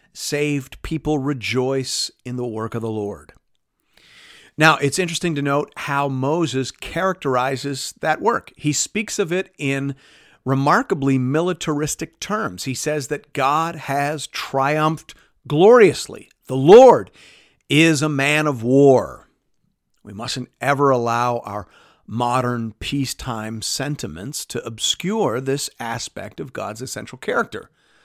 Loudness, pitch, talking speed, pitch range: -19 LUFS, 140 Hz, 120 wpm, 125-155 Hz